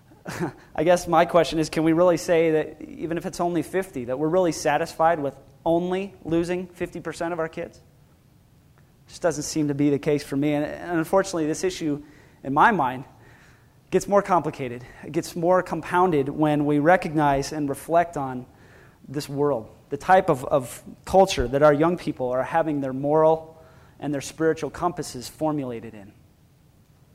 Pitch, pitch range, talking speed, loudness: 155 Hz, 140-170 Hz, 170 wpm, -23 LUFS